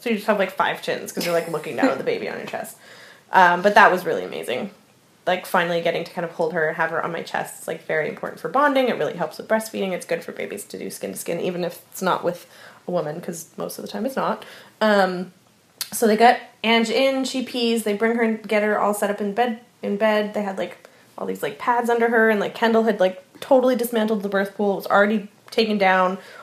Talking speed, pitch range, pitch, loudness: 265 wpm, 185-230 Hz, 210 Hz, -22 LUFS